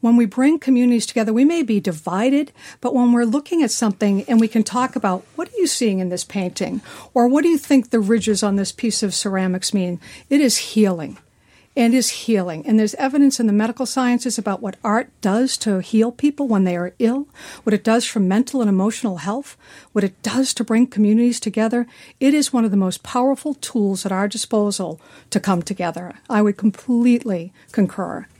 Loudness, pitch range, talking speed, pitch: -19 LUFS, 200-250 Hz, 205 wpm, 225 Hz